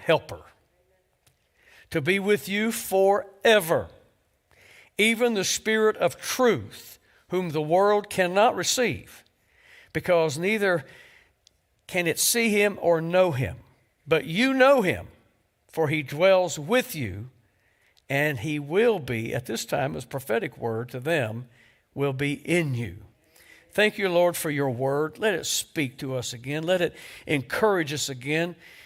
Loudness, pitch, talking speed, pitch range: -24 LUFS, 165 Hz, 140 wpm, 135-200 Hz